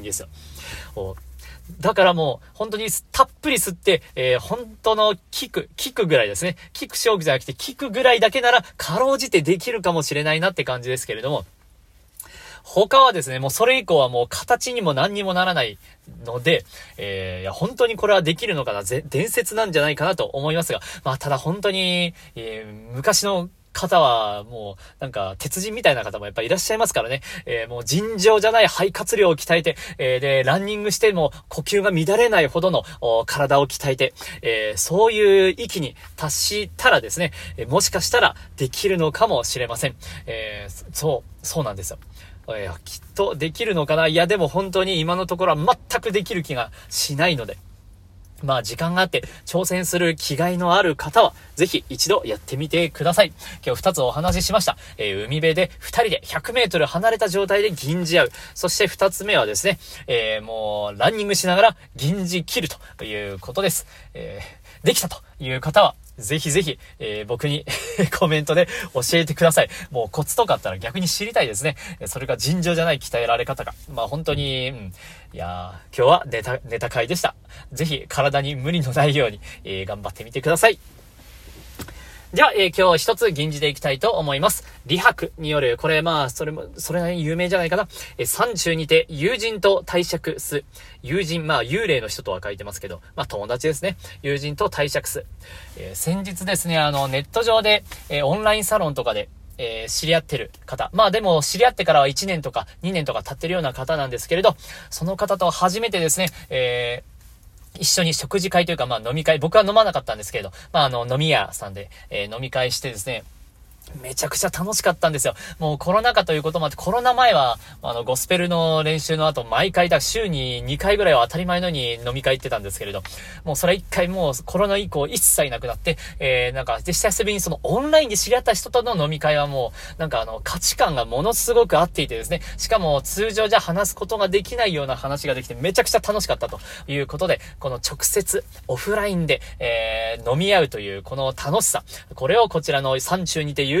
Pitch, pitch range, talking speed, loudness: 165 Hz, 130-200 Hz, 395 characters per minute, -21 LUFS